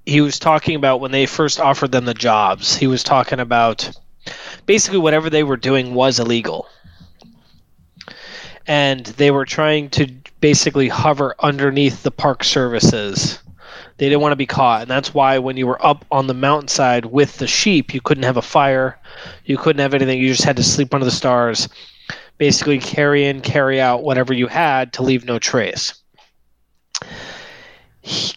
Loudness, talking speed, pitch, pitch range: -16 LUFS, 175 wpm, 135 Hz, 125-145 Hz